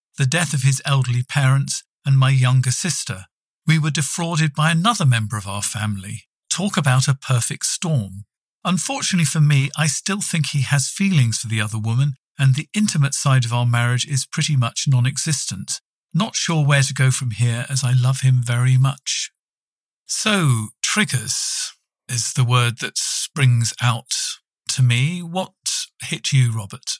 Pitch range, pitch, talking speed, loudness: 120-155 Hz, 135 Hz, 170 wpm, -19 LUFS